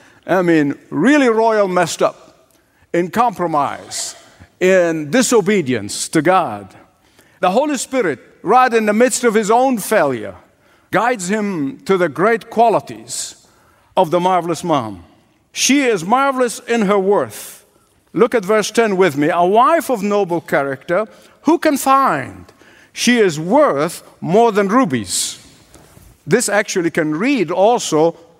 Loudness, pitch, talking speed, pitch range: -16 LUFS, 215 Hz, 135 wpm, 175-250 Hz